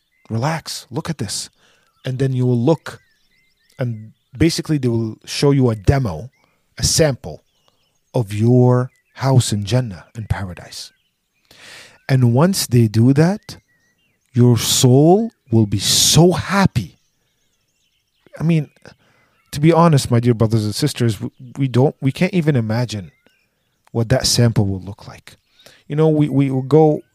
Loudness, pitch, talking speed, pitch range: -16 LUFS, 125 Hz, 145 wpm, 115-150 Hz